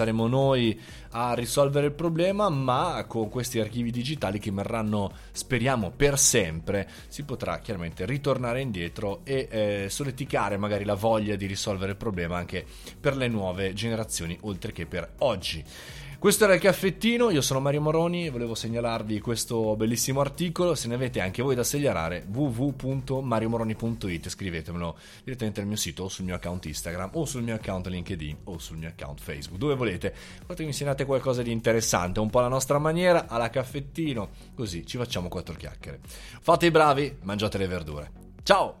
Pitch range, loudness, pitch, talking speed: 95-135 Hz, -27 LUFS, 115 Hz, 170 wpm